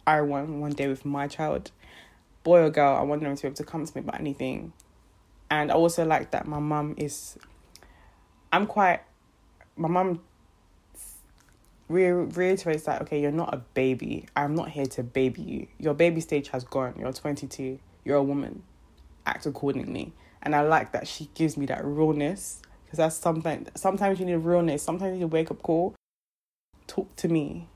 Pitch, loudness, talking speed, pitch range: 150 Hz, -27 LUFS, 180 wpm, 135-160 Hz